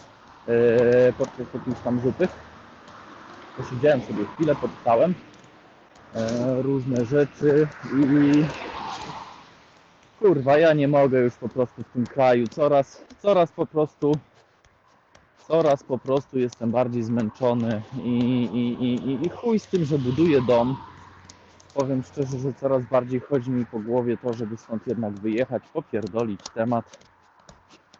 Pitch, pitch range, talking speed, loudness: 125 Hz, 115-140 Hz, 125 wpm, -23 LUFS